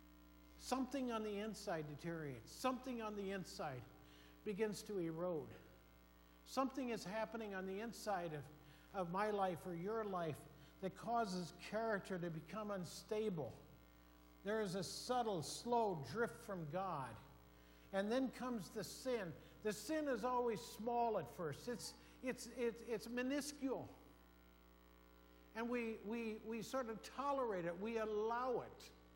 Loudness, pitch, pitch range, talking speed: -45 LUFS, 195 Hz, 150-230 Hz, 140 wpm